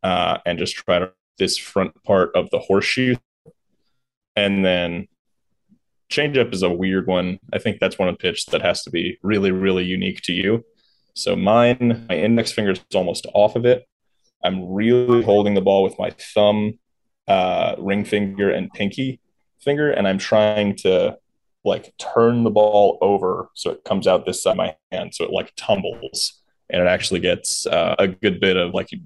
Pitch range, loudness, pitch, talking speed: 95-115 Hz, -20 LUFS, 105 Hz, 190 wpm